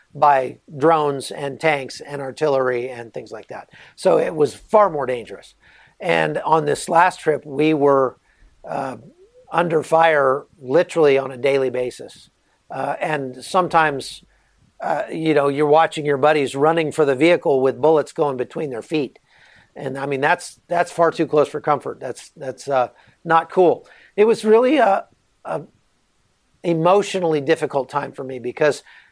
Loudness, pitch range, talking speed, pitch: -19 LUFS, 135-165 Hz, 160 wpm, 150 Hz